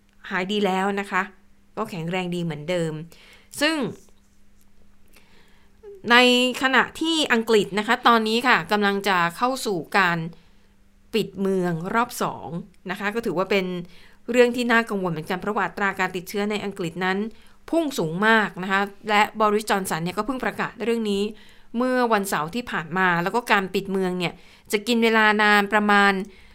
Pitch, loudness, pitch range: 200 Hz, -22 LUFS, 180-225 Hz